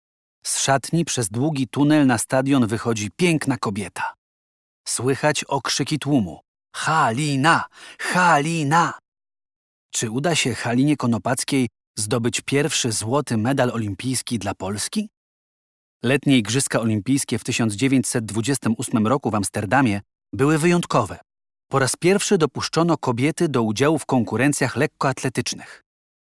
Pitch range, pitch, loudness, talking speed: 115-145 Hz, 130 Hz, -21 LUFS, 105 wpm